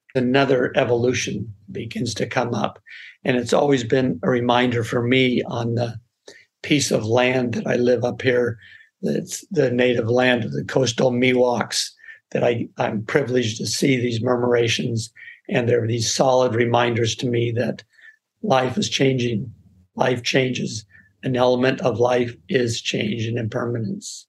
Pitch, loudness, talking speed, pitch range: 125 Hz, -21 LUFS, 155 wpm, 120-130 Hz